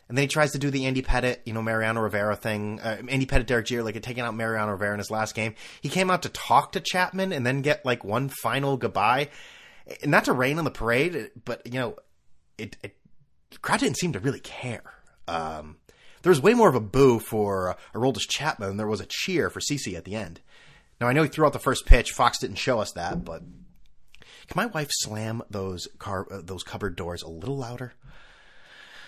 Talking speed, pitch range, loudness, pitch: 230 wpm, 105-135 Hz, -26 LUFS, 120 Hz